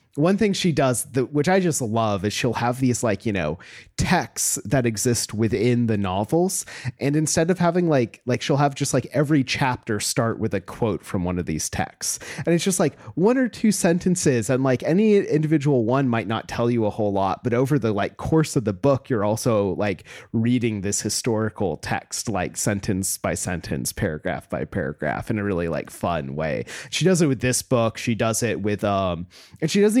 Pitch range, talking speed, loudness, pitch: 105-150 Hz, 210 wpm, -22 LUFS, 120 Hz